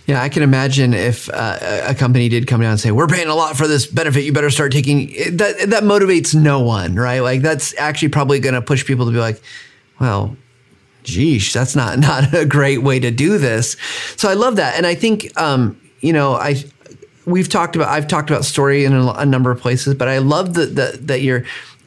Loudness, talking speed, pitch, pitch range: -15 LUFS, 230 wpm, 140 Hz, 125-150 Hz